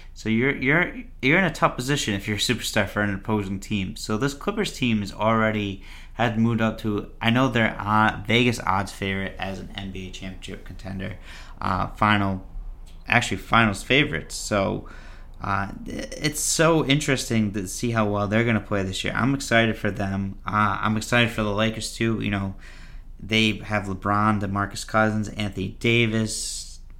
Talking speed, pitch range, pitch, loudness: 175 wpm, 95-115 Hz, 105 Hz, -23 LUFS